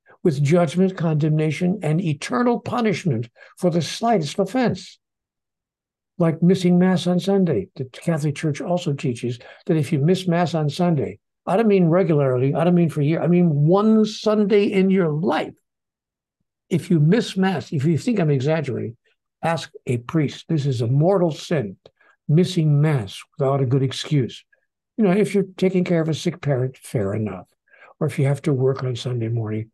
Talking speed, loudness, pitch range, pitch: 180 wpm, -21 LUFS, 140-185 Hz, 165 Hz